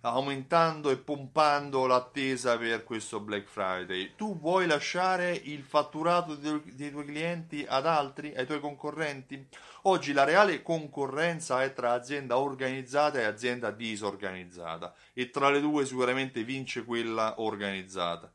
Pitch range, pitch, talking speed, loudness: 115-150 Hz, 135 Hz, 135 wpm, -30 LUFS